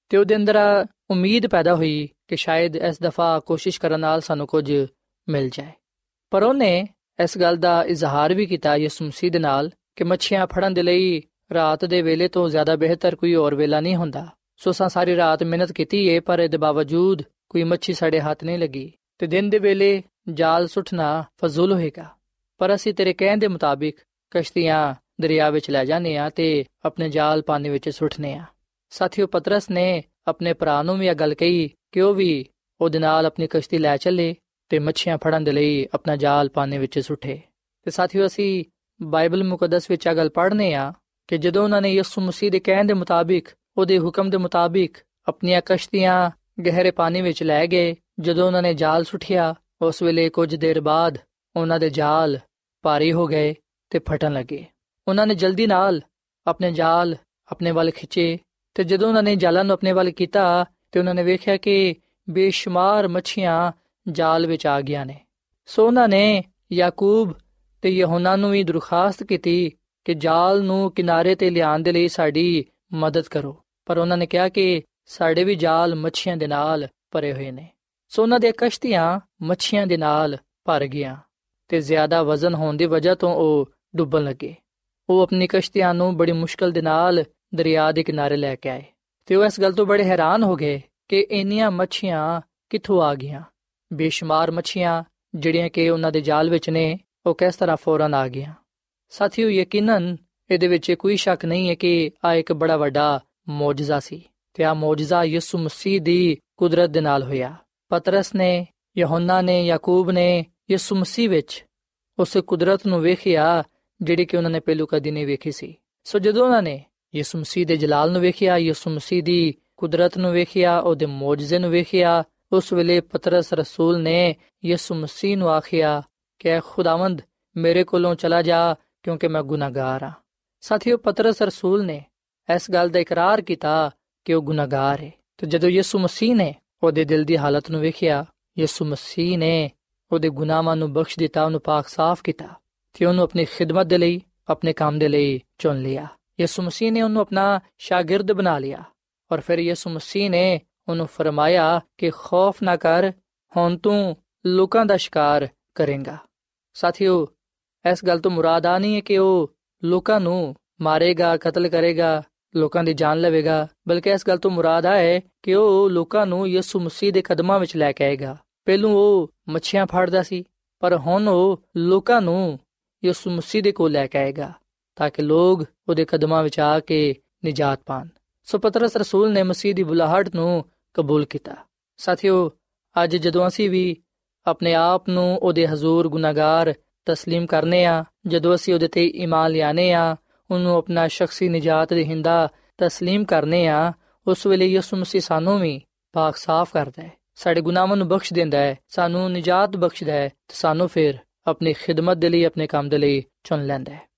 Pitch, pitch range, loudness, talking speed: 170 Hz, 155-185 Hz, -20 LUFS, 170 wpm